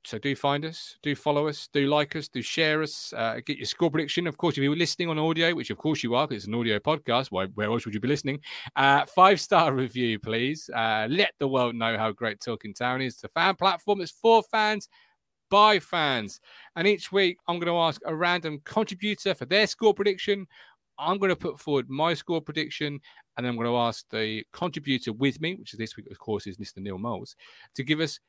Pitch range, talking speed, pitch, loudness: 120-175 Hz, 235 wpm, 150 Hz, -26 LUFS